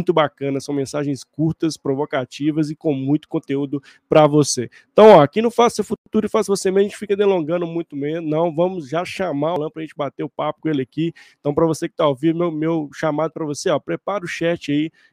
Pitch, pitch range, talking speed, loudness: 160 Hz, 145-175 Hz, 235 wpm, -19 LUFS